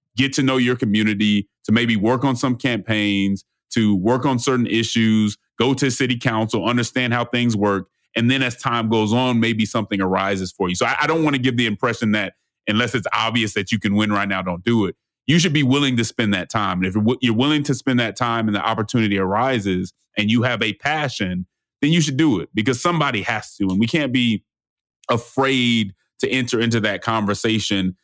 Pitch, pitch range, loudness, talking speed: 115 Hz, 105-125 Hz, -19 LUFS, 215 wpm